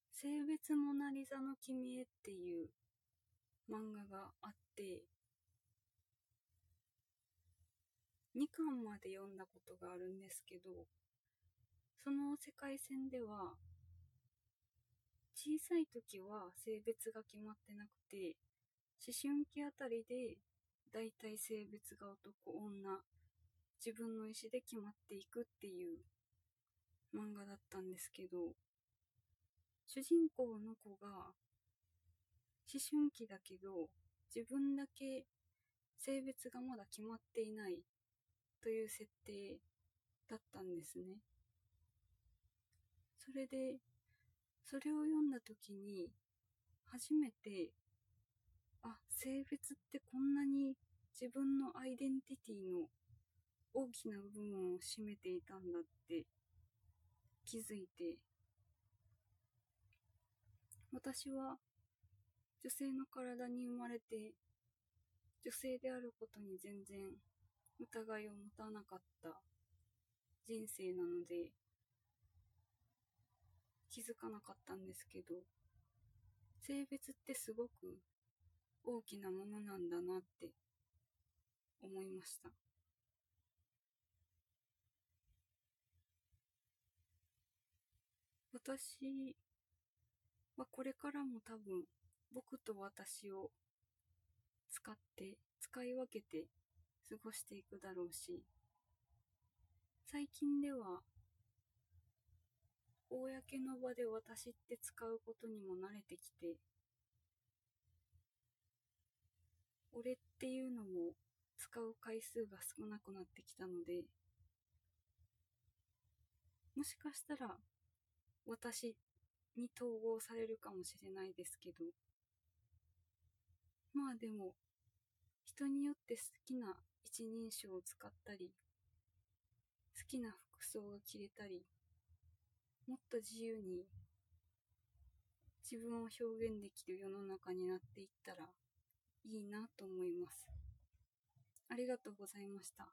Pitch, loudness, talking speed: 175 Hz, -49 LUFS, 185 characters per minute